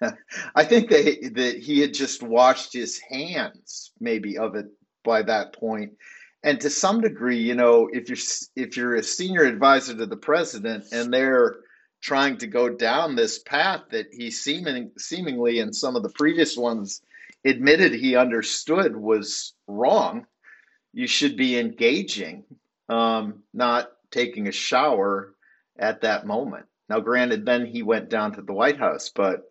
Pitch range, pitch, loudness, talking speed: 115-145 Hz, 120 Hz, -22 LUFS, 155 wpm